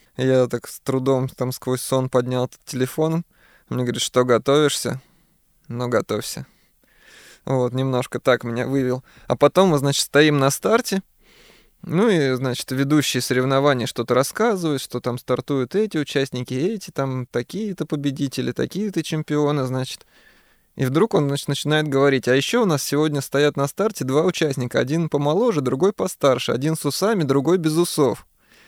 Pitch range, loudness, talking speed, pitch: 130-155 Hz, -21 LUFS, 155 wpm, 140 Hz